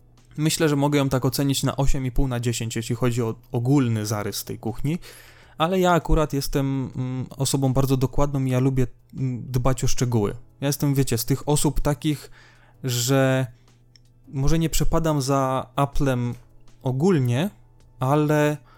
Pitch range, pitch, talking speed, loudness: 120-145 Hz, 130 Hz, 145 wpm, -23 LUFS